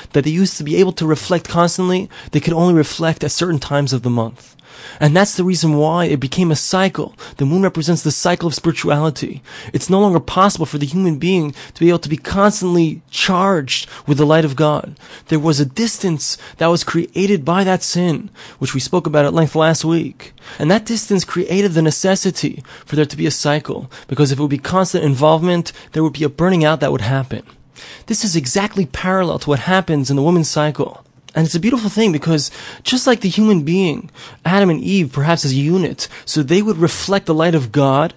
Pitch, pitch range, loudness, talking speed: 165 Hz, 150-185 Hz, -16 LUFS, 215 wpm